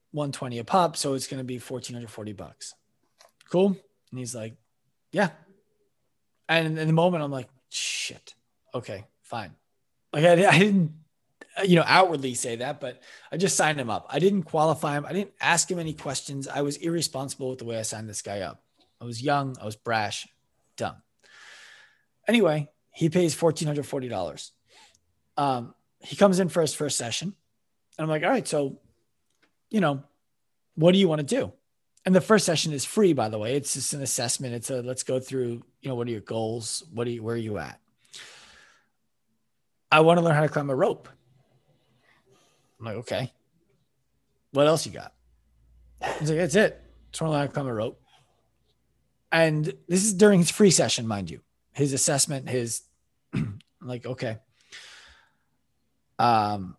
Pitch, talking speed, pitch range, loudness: 140 Hz, 180 wpm, 120-165 Hz, -25 LUFS